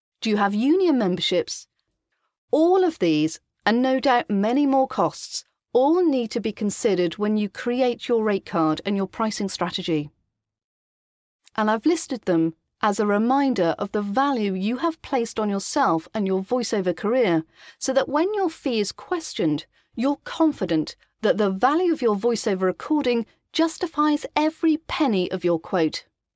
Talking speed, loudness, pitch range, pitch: 155 wpm, -23 LUFS, 190-270 Hz, 220 Hz